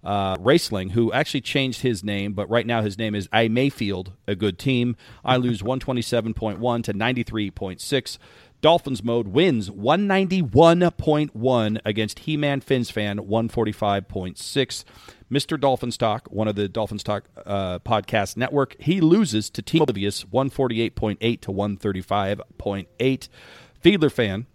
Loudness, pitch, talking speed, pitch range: -23 LUFS, 115 Hz, 130 wpm, 105-130 Hz